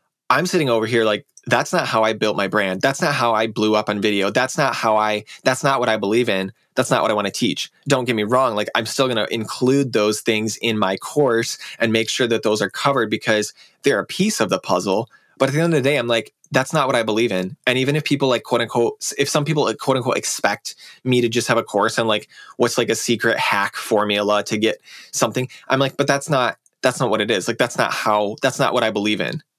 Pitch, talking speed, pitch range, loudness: 115 Hz, 270 wpm, 110-135 Hz, -19 LUFS